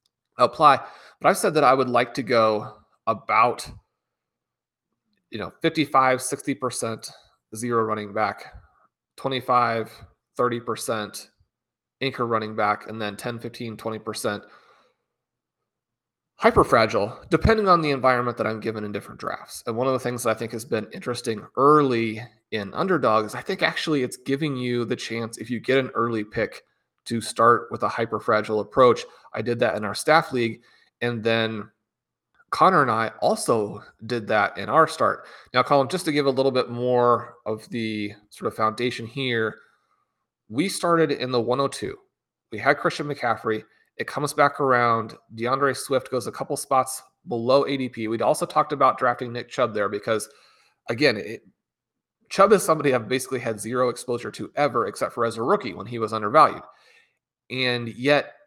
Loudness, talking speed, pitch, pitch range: -23 LUFS, 170 wpm, 120 Hz, 110-135 Hz